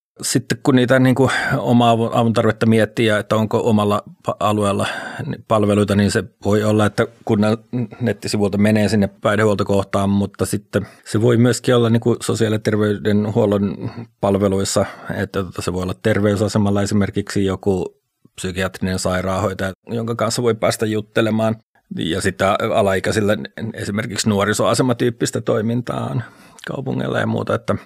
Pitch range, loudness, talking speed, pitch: 100-115 Hz, -18 LUFS, 125 wpm, 105 Hz